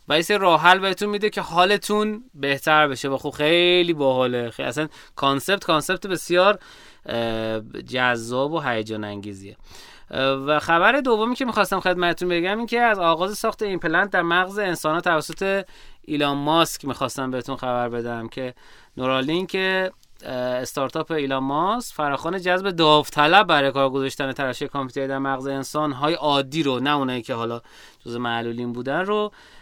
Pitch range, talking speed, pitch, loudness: 130-185 Hz, 155 wpm, 150 Hz, -21 LUFS